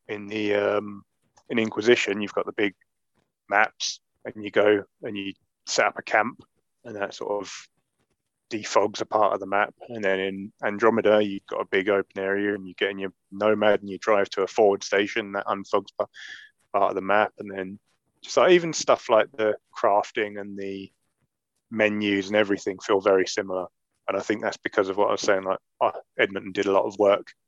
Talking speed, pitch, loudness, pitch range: 200 wpm, 100 Hz, -24 LUFS, 100-105 Hz